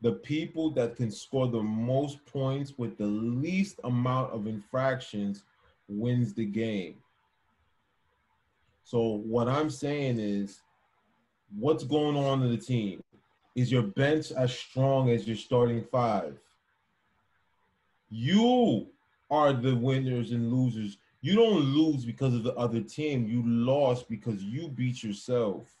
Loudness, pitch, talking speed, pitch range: -29 LUFS, 120 Hz, 135 wpm, 110-135 Hz